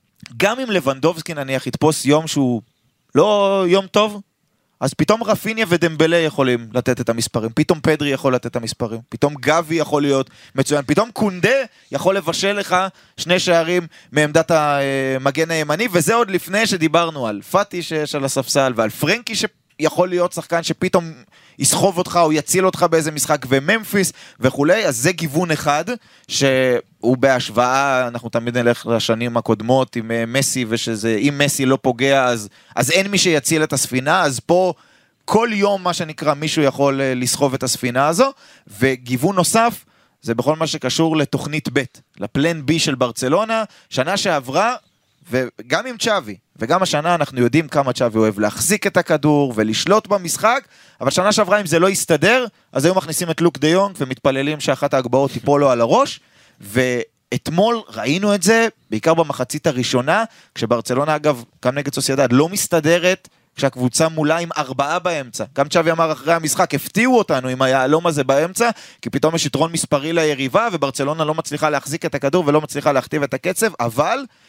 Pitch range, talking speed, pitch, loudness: 130-175 Hz, 155 wpm, 150 Hz, -18 LUFS